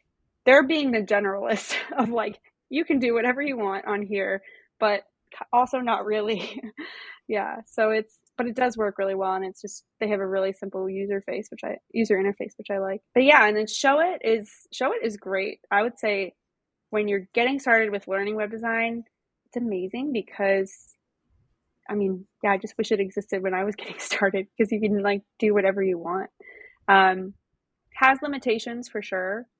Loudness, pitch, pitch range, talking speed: -25 LUFS, 215 Hz, 195-235 Hz, 195 wpm